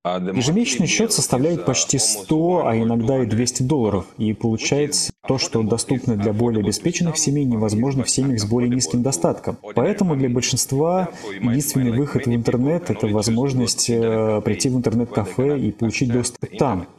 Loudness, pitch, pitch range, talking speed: -20 LUFS, 125 Hz, 115-140 Hz, 150 wpm